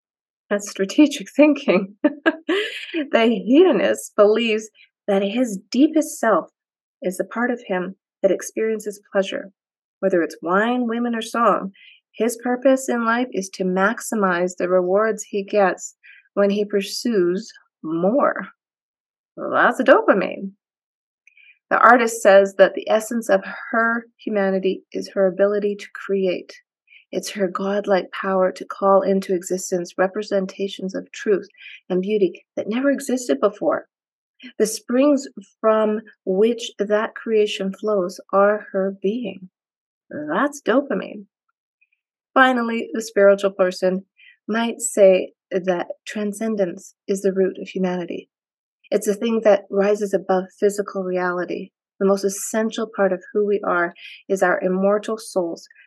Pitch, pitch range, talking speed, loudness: 205 Hz, 195-235 Hz, 130 wpm, -20 LUFS